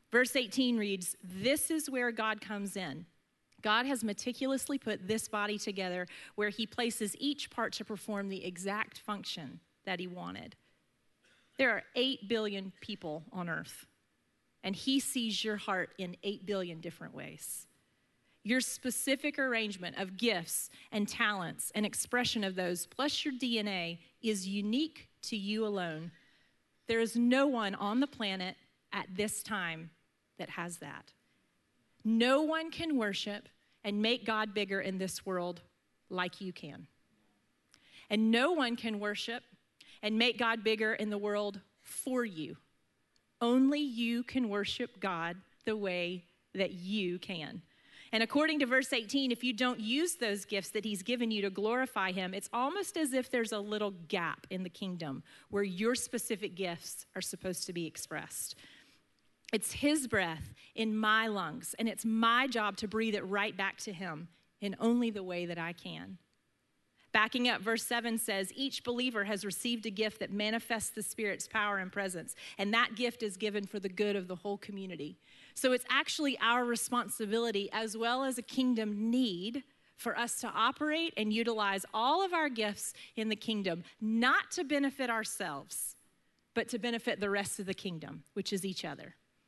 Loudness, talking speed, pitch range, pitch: -34 LUFS, 165 wpm, 195-240 Hz, 215 Hz